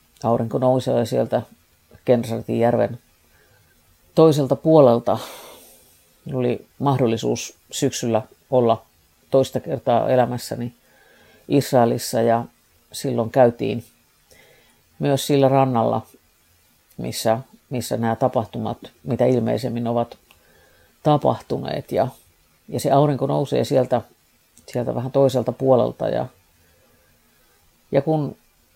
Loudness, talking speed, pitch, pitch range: -21 LUFS, 90 wpm, 120 Hz, 115-135 Hz